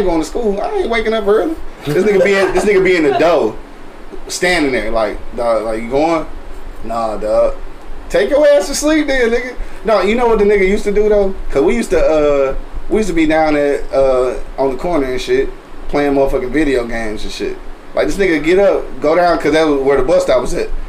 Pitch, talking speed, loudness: 195 Hz, 240 wpm, -14 LUFS